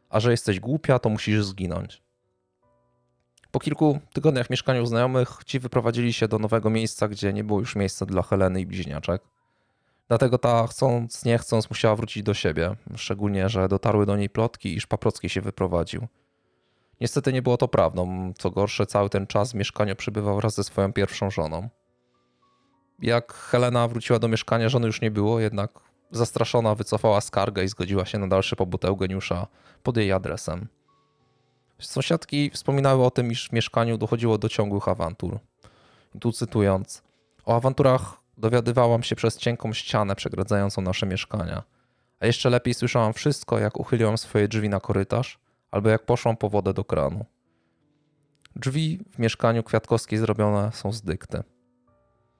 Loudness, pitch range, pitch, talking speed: -24 LUFS, 100-120 Hz, 110 Hz, 160 wpm